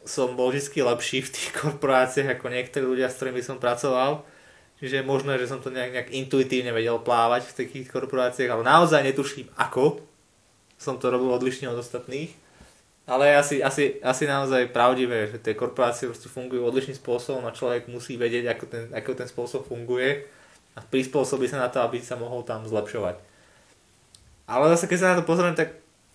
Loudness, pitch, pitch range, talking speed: -25 LUFS, 130 Hz, 120-135 Hz, 180 wpm